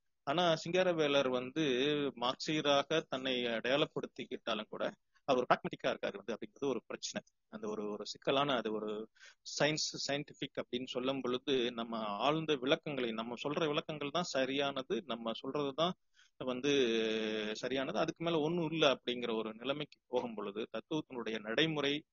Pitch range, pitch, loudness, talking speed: 120-150 Hz, 135 Hz, -36 LUFS, 120 wpm